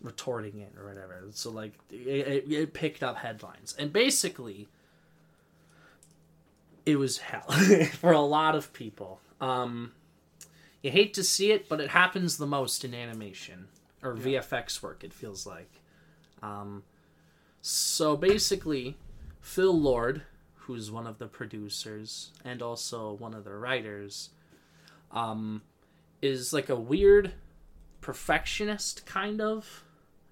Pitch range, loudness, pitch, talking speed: 105-155 Hz, -28 LUFS, 130 Hz, 130 wpm